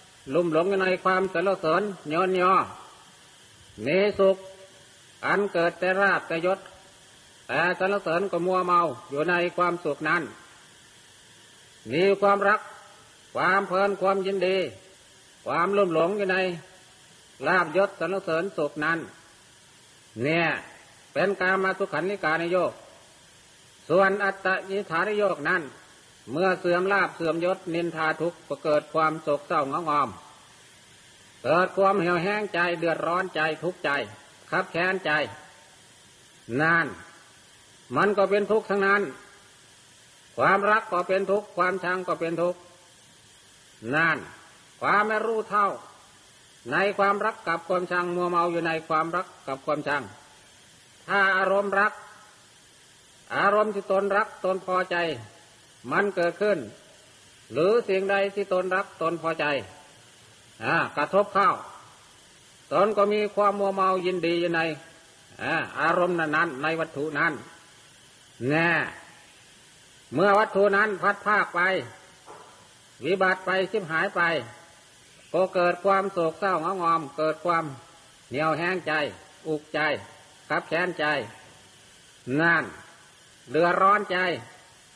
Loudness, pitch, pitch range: -25 LUFS, 180 Hz, 165-195 Hz